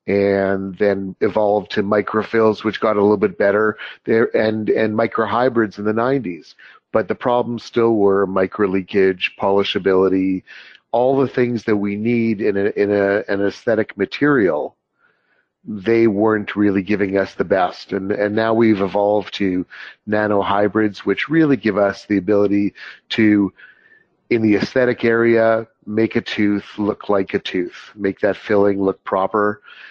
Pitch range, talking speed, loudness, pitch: 100-115 Hz, 150 wpm, -18 LUFS, 105 Hz